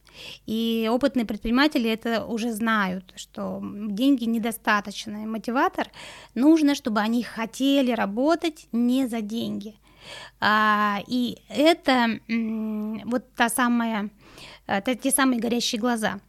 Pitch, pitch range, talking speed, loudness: 230 Hz, 215-255 Hz, 100 wpm, -24 LUFS